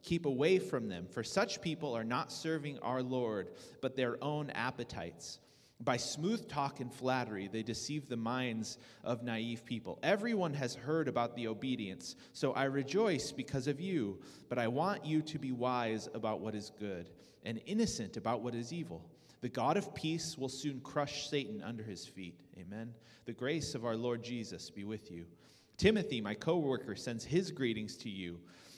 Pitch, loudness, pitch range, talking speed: 125 Hz, -38 LUFS, 115-145 Hz, 180 wpm